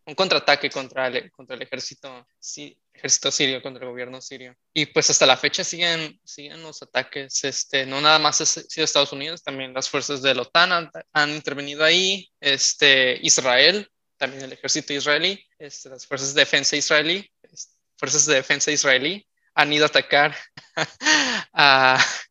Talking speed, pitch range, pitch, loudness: 170 wpm, 135-155 Hz, 145 Hz, -19 LUFS